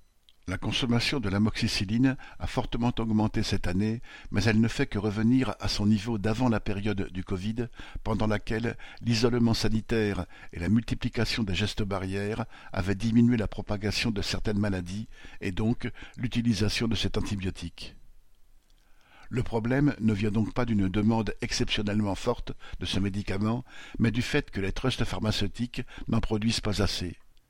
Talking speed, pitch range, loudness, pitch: 155 wpm, 100-120 Hz, -29 LUFS, 110 Hz